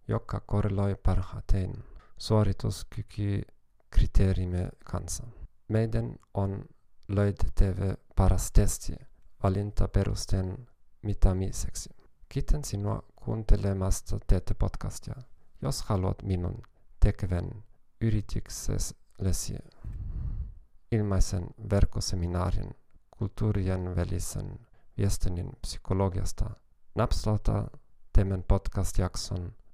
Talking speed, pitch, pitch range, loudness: 65 wpm, 100 Hz, 95-110 Hz, -31 LUFS